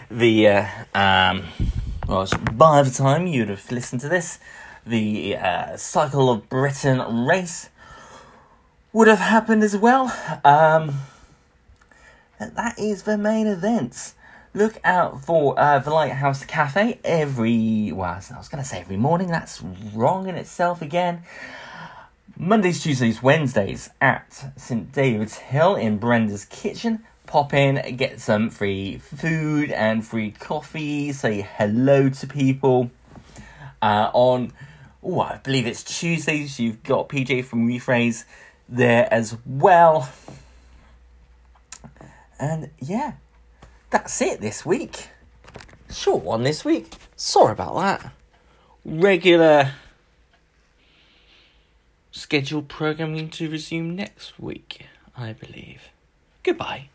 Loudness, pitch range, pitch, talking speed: -21 LUFS, 110-160 Hz, 135 Hz, 120 wpm